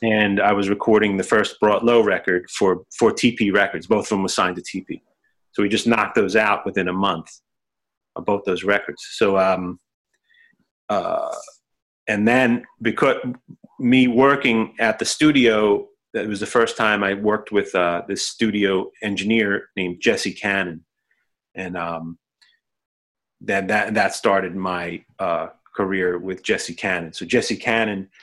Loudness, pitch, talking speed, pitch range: -20 LUFS, 105 Hz, 155 wpm, 95-115 Hz